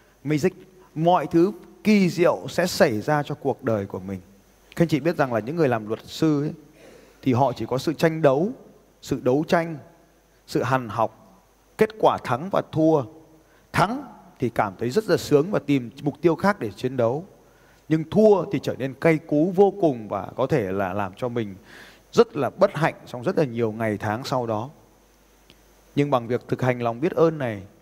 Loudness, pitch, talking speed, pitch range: -23 LUFS, 145 Hz, 205 wpm, 115-170 Hz